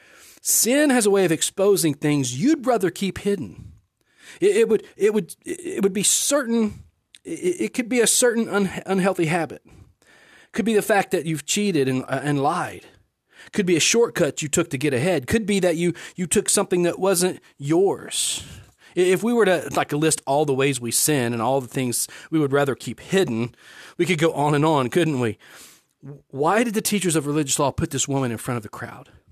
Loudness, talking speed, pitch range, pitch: -21 LUFS, 210 wpm, 140-205 Hz, 175 Hz